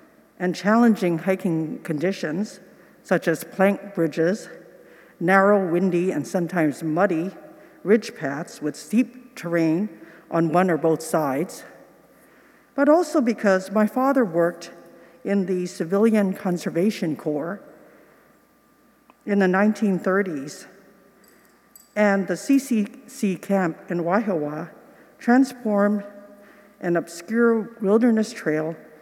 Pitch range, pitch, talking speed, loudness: 170-225 Hz, 195 Hz, 100 wpm, -22 LUFS